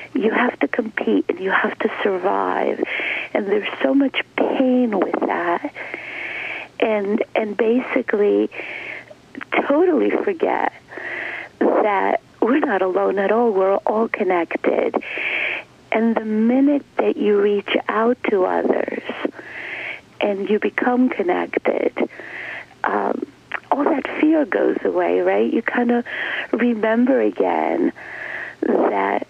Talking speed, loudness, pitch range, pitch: 115 wpm, -20 LUFS, 210-310 Hz, 240 Hz